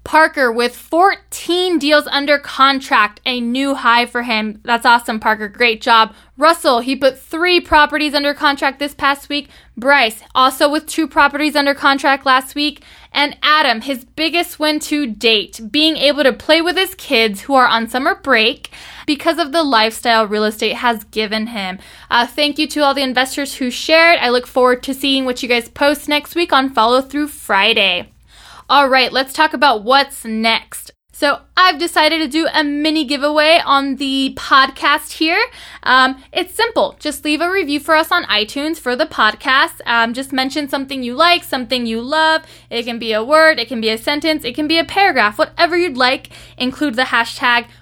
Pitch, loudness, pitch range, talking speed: 275 Hz, -14 LUFS, 240-310 Hz, 185 wpm